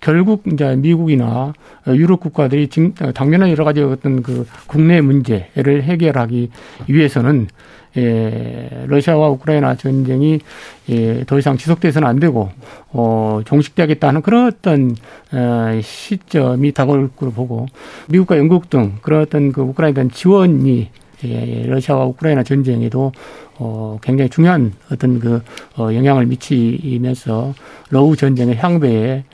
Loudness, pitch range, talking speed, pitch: -15 LUFS, 120-155 Hz, 285 characters per minute, 135 Hz